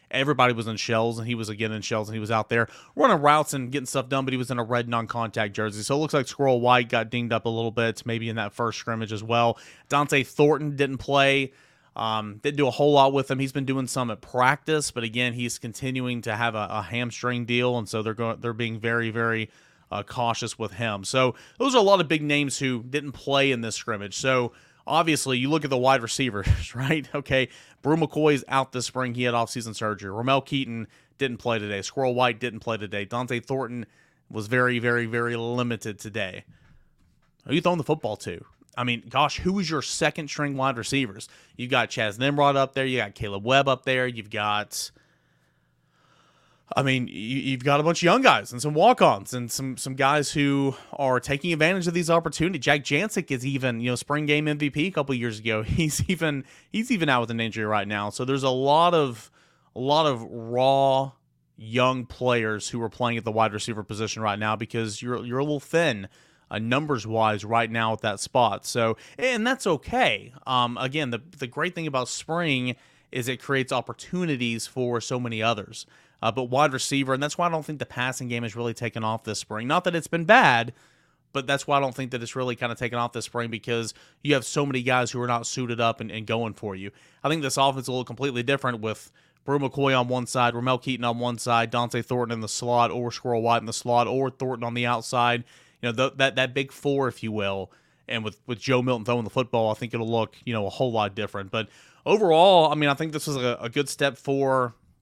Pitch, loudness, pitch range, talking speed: 125 Hz, -25 LUFS, 115-140 Hz, 230 wpm